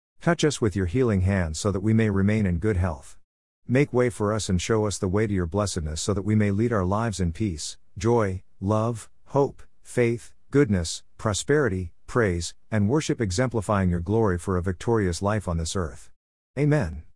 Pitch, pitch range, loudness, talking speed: 105 Hz, 90-115 Hz, -25 LUFS, 190 wpm